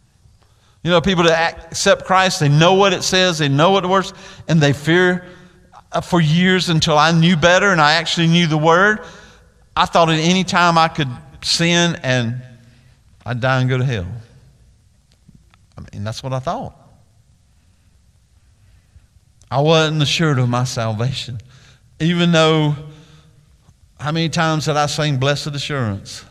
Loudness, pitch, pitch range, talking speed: -16 LUFS, 150 Hz, 120-170 Hz, 155 wpm